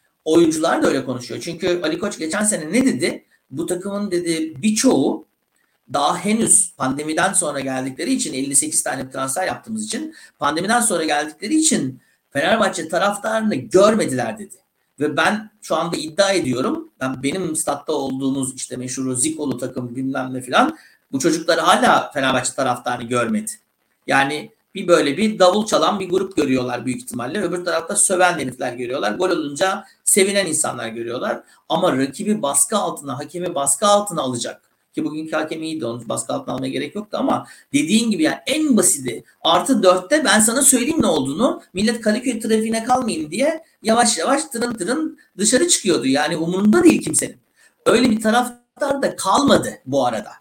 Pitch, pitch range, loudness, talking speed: 185 Hz, 145-235 Hz, -19 LUFS, 155 wpm